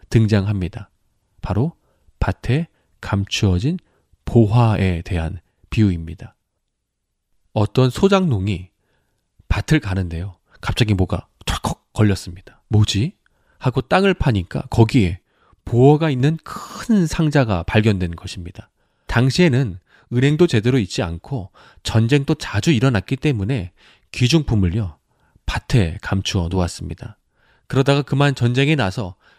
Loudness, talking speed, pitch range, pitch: -19 LUFS, 260 characters per minute, 95-135 Hz, 110 Hz